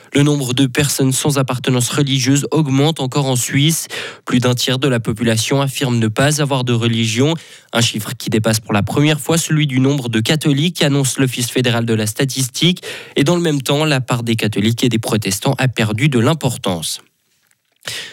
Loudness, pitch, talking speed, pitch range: -16 LUFS, 135 Hz, 190 wpm, 120-145 Hz